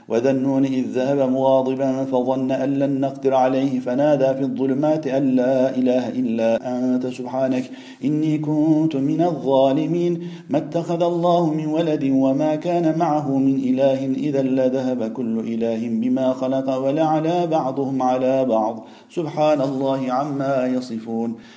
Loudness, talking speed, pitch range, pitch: -20 LUFS, 130 wpm, 130-150 Hz, 135 Hz